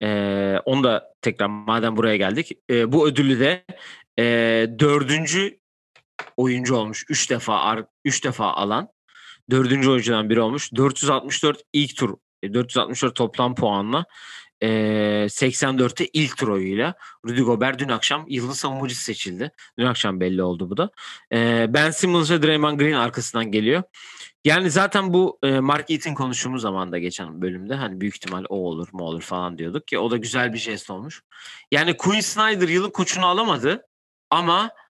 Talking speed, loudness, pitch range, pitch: 150 wpm, -21 LUFS, 105-145 Hz, 125 Hz